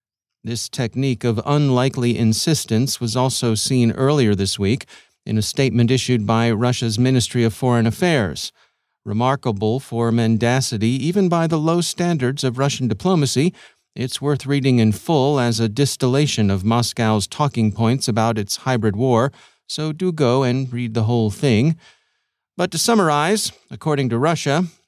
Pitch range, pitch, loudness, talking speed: 115-145 Hz, 125 Hz, -19 LUFS, 150 wpm